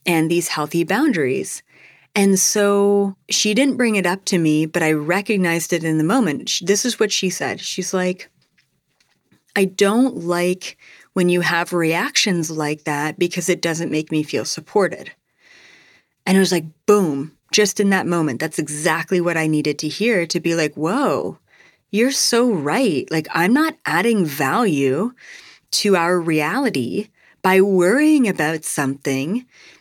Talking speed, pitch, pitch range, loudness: 155 wpm, 180 Hz, 160-205 Hz, -18 LUFS